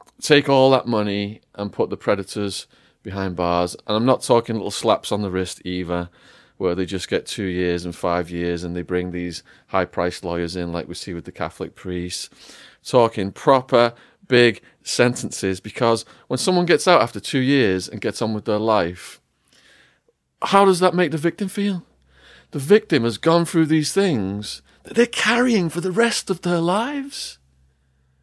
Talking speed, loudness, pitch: 180 wpm, -20 LUFS, 105 Hz